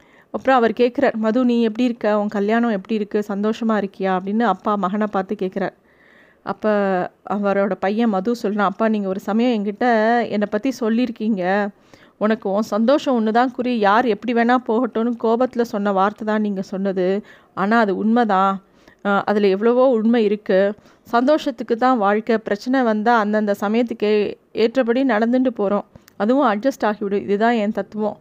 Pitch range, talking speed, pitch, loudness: 200-235 Hz, 145 wpm, 215 Hz, -19 LUFS